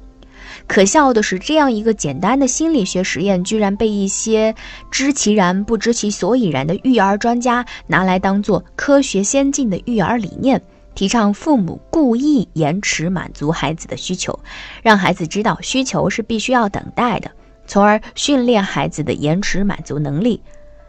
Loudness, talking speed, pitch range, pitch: -16 LUFS, 260 characters per minute, 180-240 Hz, 210 Hz